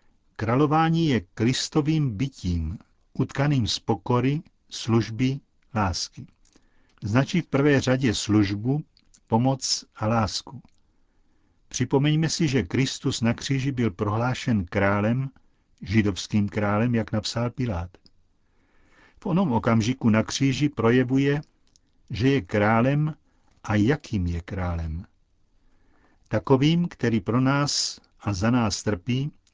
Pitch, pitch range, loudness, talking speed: 115 Hz, 105-135 Hz, -24 LUFS, 105 wpm